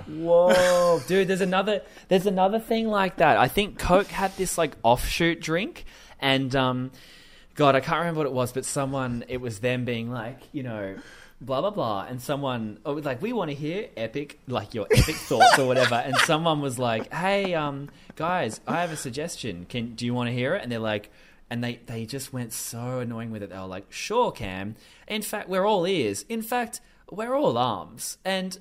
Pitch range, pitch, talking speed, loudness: 120-180 Hz, 140 Hz, 210 wpm, -25 LUFS